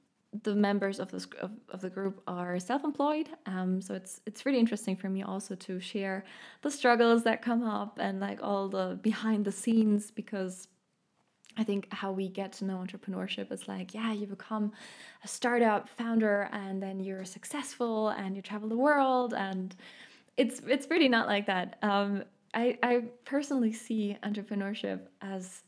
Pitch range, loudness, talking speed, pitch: 195-230 Hz, -32 LUFS, 170 wpm, 205 Hz